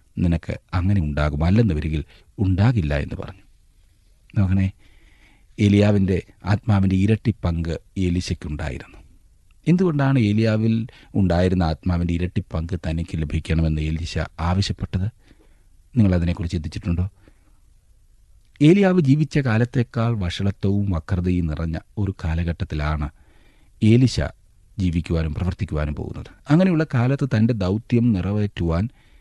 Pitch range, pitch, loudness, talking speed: 85-105 Hz, 95 Hz, -22 LUFS, 85 wpm